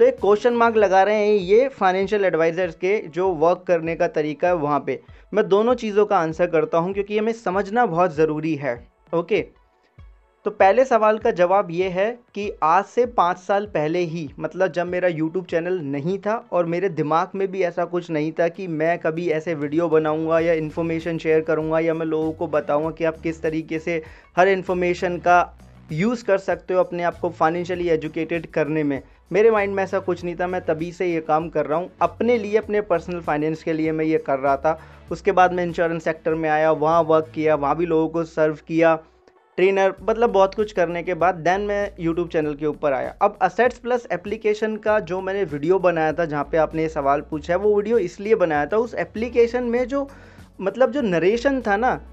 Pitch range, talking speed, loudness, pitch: 160-200 Hz, 215 wpm, -21 LUFS, 175 Hz